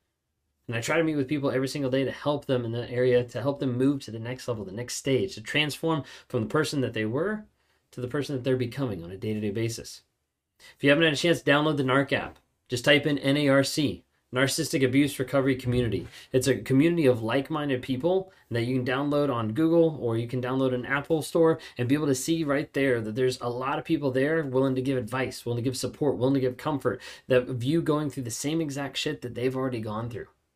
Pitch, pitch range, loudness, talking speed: 130 Hz, 125-145 Hz, -27 LUFS, 245 wpm